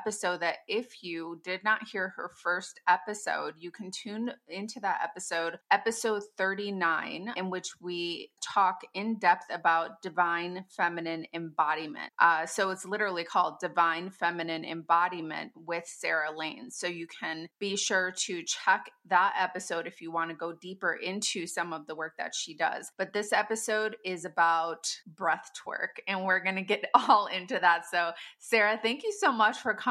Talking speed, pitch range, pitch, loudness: 170 wpm, 170-205 Hz, 180 Hz, -30 LUFS